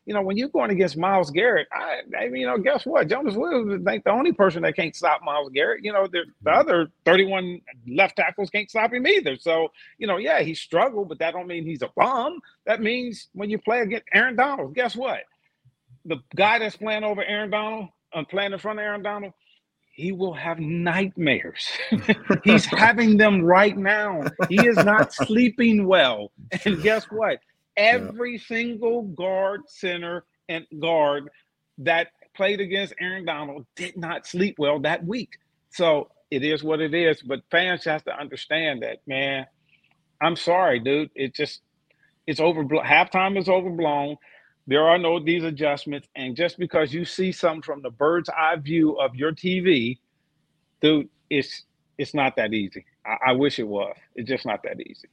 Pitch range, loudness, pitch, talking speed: 155-210 Hz, -22 LUFS, 180 Hz, 180 wpm